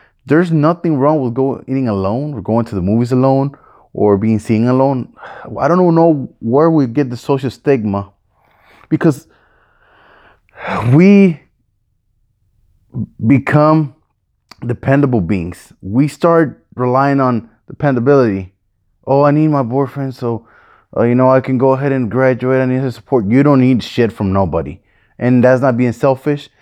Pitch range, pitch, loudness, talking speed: 110-140 Hz, 130 Hz, -14 LUFS, 150 wpm